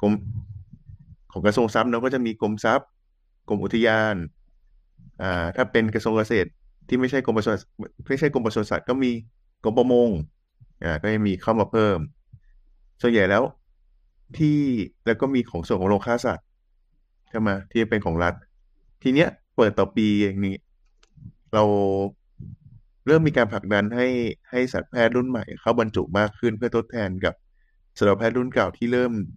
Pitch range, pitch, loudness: 100-120 Hz, 110 Hz, -23 LUFS